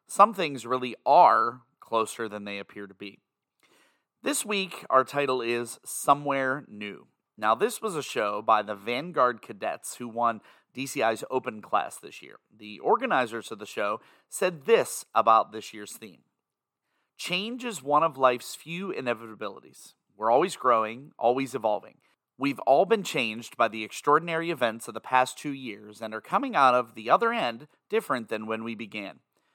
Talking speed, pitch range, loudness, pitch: 165 wpm, 110-145 Hz, -27 LUFS, 120 Hz